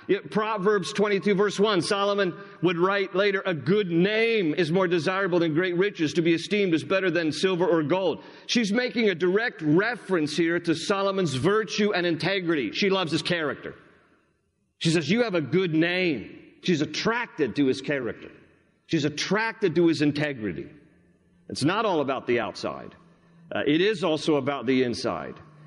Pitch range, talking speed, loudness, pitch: 160-205 Hz, 165 wpm, -25 LUFS, 180 Hz